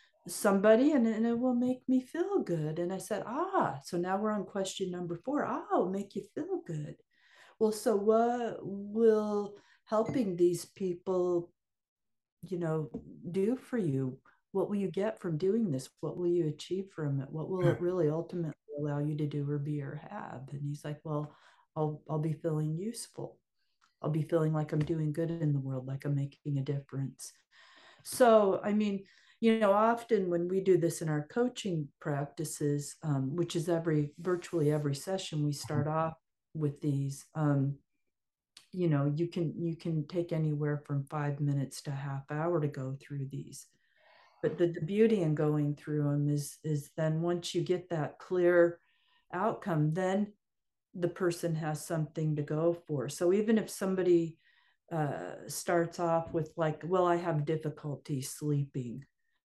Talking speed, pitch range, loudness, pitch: 175 wpm, 150-190 Hz, -32 LUFS, 165 Hz